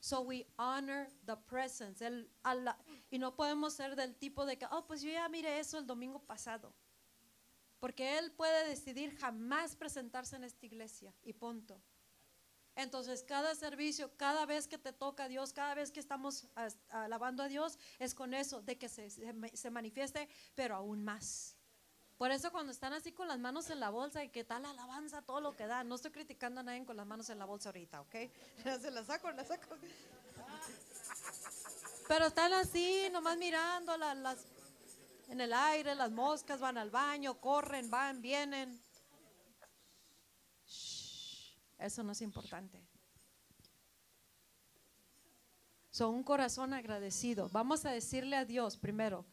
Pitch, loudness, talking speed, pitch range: 265 Hz, -41 LUFS, 160 wpm, 240-295 Hz